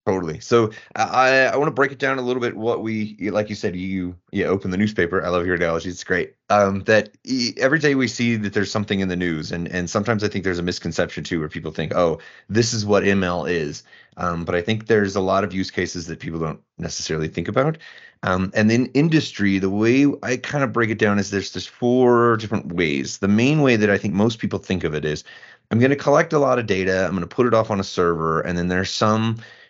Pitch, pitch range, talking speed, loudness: 105 Hz, 90-120 Hz, 255 wpm, -21 LUFS